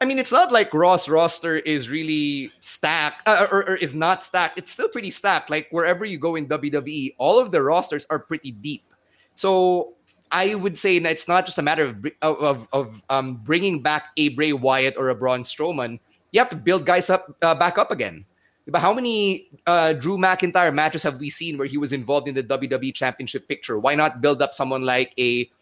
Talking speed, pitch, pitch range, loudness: 215 wpm, 155 Hz, 140-180 Hz, -21 LUFS